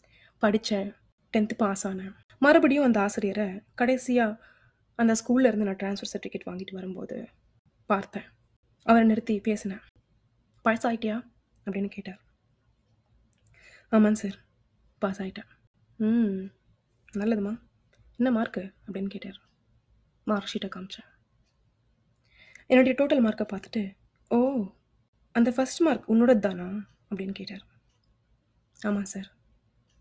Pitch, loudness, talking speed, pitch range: 205 Hz, -27 LUFS, 100 wpm, 190-225 Hz